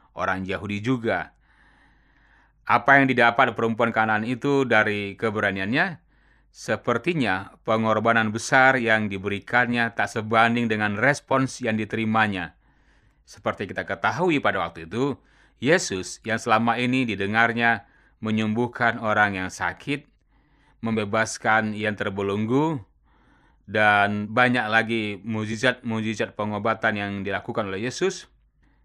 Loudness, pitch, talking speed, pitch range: -23 LUFS, 110 Hz, 100 wpm, 105-120 Hz